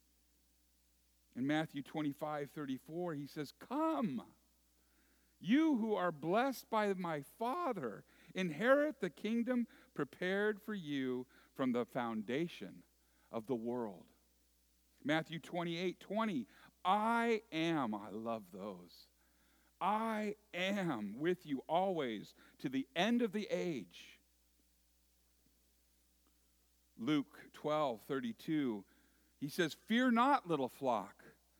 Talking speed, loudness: 105 wpm, -38 LUFS